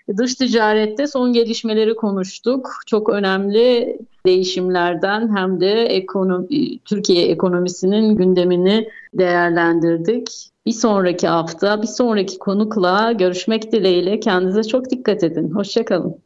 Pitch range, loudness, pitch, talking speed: 185-230 Hz, -17 LUFS, 205 Hz, 105 wpm